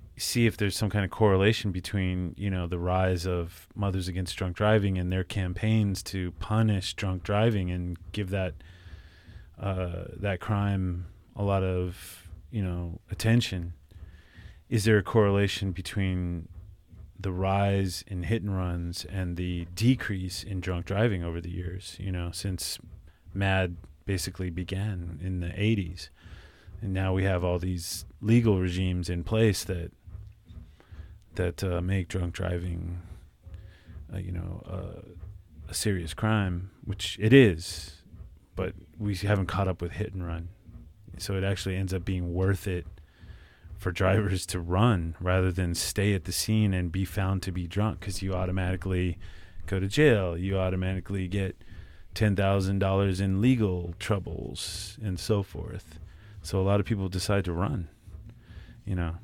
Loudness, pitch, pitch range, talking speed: -29 LUFS, 95 Hz, 90-100 Hz, 155 wpm